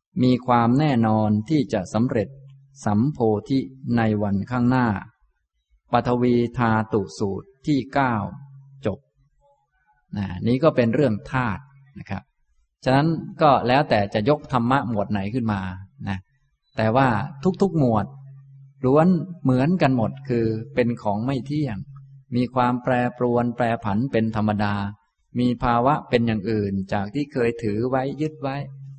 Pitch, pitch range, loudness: 125 Hz, 110-135 Hz, -22 LUFS